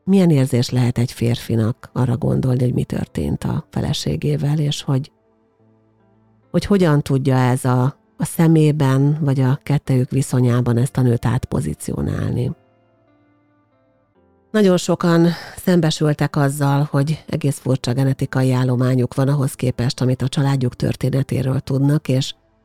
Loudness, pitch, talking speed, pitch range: -18 LUFS, 130 Hz, 125 wpm, 120-145 Hz